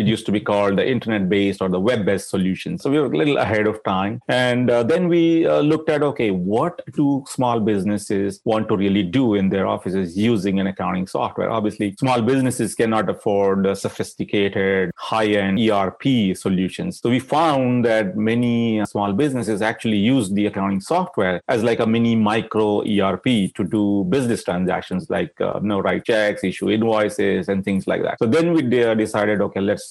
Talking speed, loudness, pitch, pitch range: 190 wpm, -20 LUFS, 105 Hz, 100-120 Hz